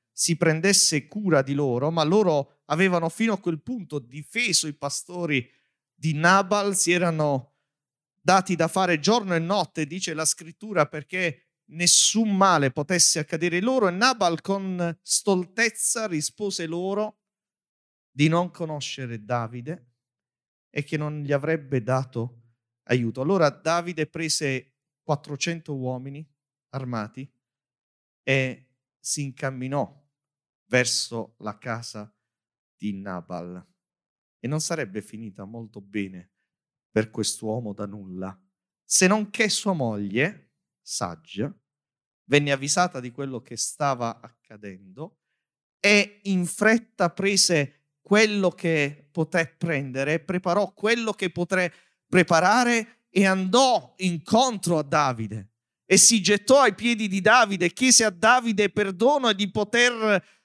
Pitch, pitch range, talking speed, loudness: 160 Hz, 130-195 Hz, 120 wpm, -23 LUFS